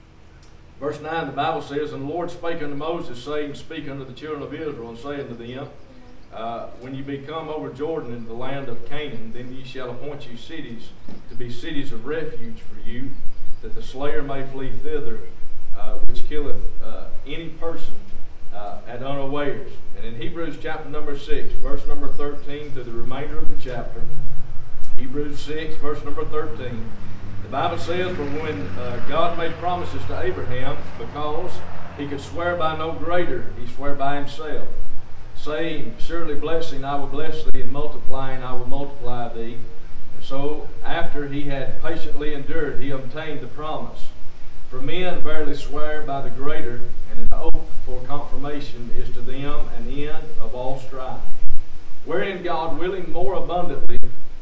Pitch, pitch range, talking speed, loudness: 140 Hz, 120-150 Hz, 170 wpm, -29 LUFS